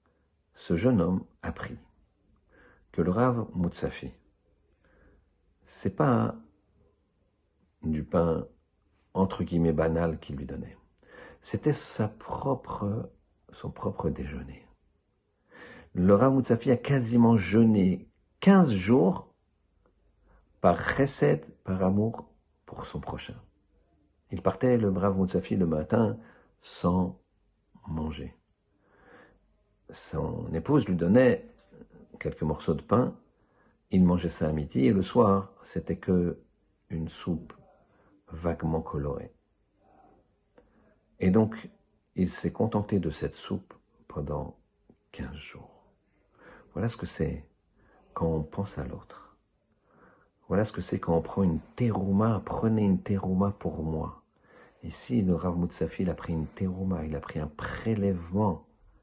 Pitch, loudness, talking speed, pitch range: 95 Hz, -28 LUFS, 120 wpm, 80-105 Hz